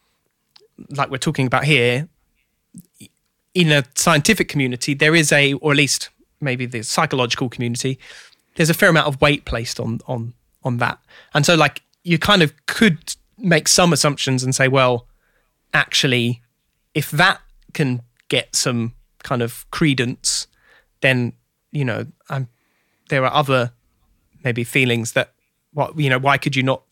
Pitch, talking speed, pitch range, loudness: 135 Hz, 155 wpm, 125-150 Hz, -18 LUFS